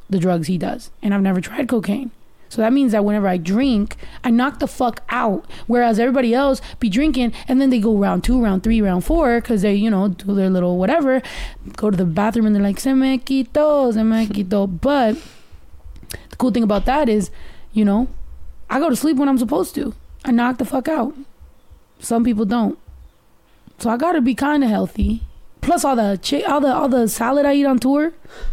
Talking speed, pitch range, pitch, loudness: 215 wpm, 200-265 Hz, 235 Hz, -18 LUFS